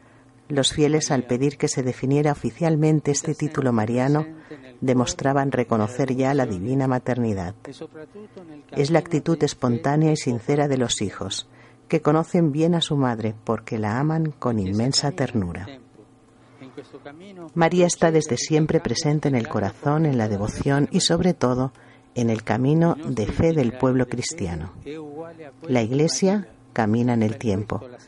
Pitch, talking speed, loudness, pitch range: 135 Hz, 140 wpm, -22 LUFS, 120-155 Hz